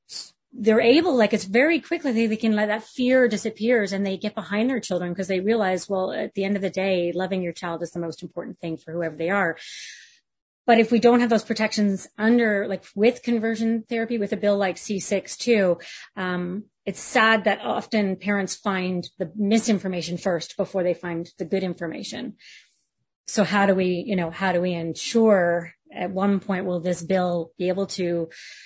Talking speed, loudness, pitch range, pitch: 205 wpm, -23 LUFS, 180-220 Hz, 195 Hz